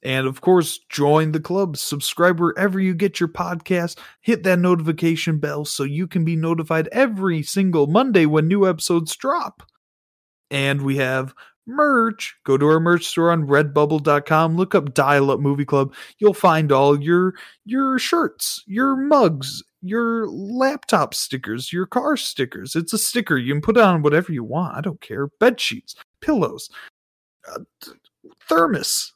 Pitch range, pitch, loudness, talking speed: 145-200 Hz, 170 Hz, -19 LUFS, 160 wpm